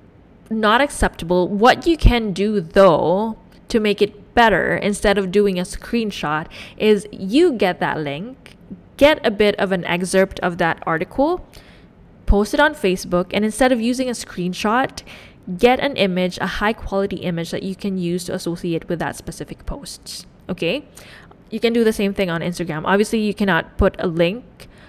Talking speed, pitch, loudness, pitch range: 175 wpm, 200 Hz, -19 LUFS, 180-225 Hz